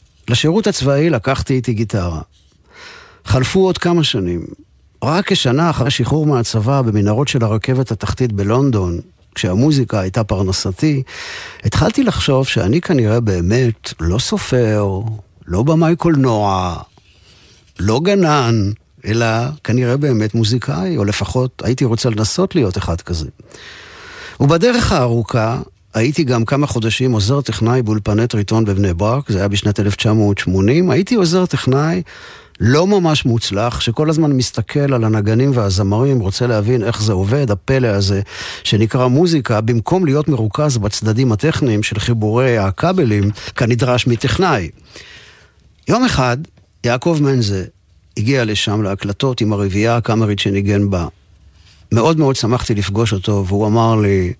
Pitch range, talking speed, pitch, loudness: 105-135 Hz, 125 wpm, 115 Hz, -15 LUFS